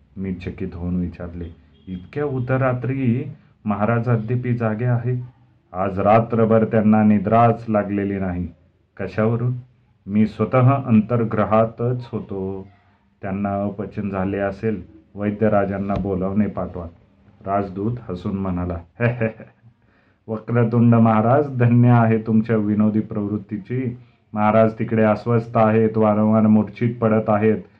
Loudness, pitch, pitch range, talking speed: -20 LUFS, 110 Hz, 100-115 Hz, 100 wpm